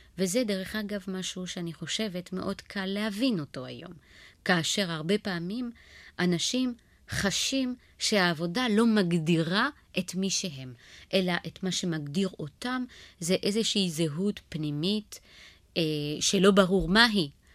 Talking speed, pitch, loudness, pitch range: 115 wpm, 190 Hz, -28 LUFS, 170-210 Hz